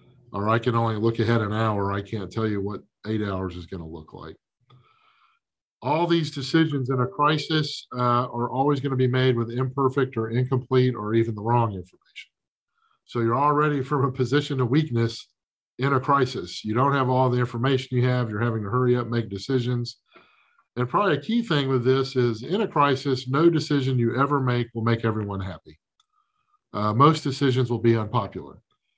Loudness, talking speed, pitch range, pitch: -24 LUFS, 195 wpm, 115-140 Hz, 125 Hz